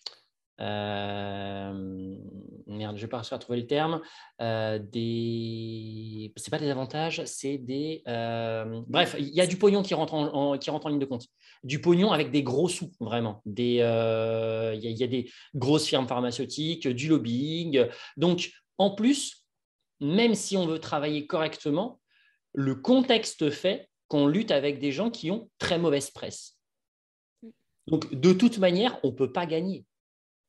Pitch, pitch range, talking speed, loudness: 140 Hz, 115-170 Hz, 165 wpm, -28 LUFS